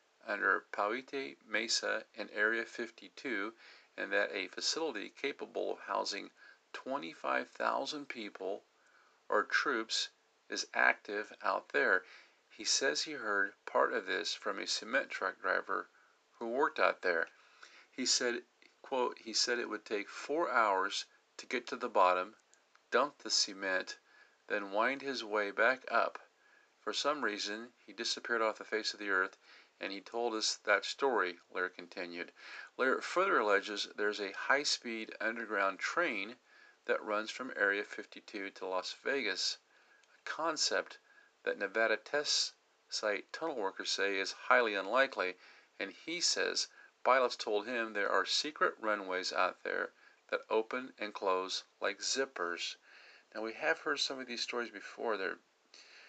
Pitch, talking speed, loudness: 150 Hz, 145 wpm, -35 LUFS